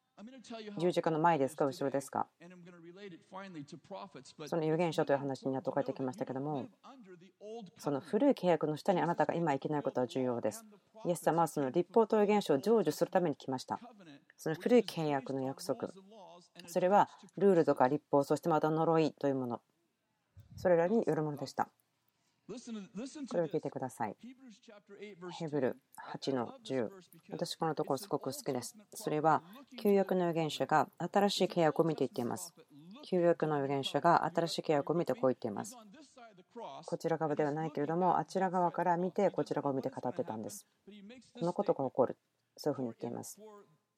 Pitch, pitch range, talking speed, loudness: 165 Hz, 145-195 Hz, 325 characters per minute, -34 LUFS